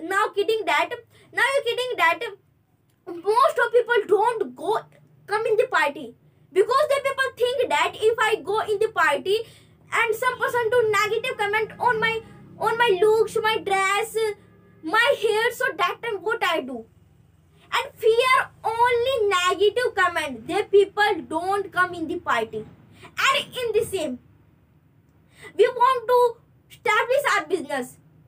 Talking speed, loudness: 150 wpm, -22 LUFS